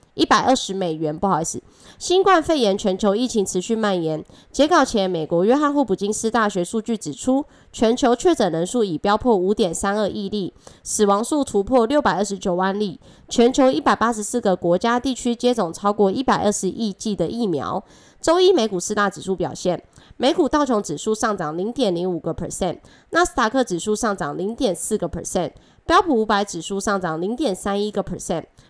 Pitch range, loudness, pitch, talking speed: 190-245 Hz, -20 LUFS, 210 Hz, 335 characters per minute